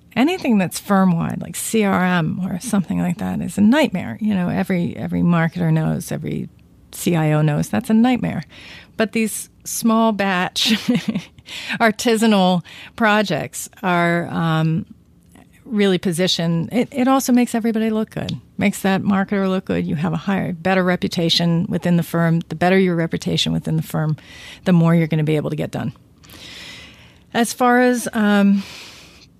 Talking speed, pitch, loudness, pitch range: 155 wpm, 190 Hz, -19 LUFS, 170-220 Hz